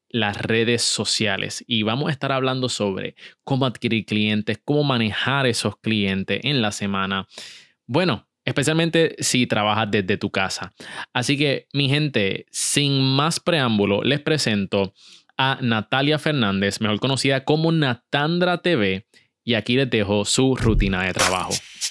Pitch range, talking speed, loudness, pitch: 105-140 Hz, 140 wpm, -21 LUFS, 120 Hz